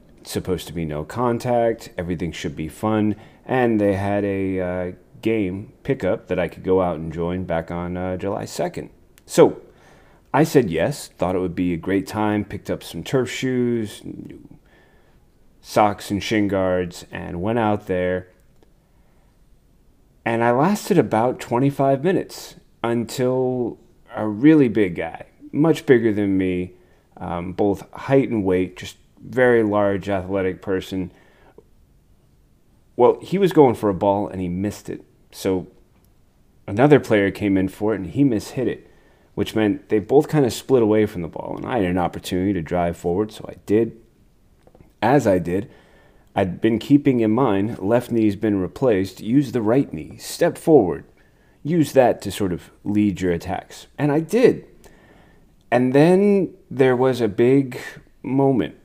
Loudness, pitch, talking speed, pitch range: -21 LUFS, 105 Hz, 160 wpm, 90-120 Hz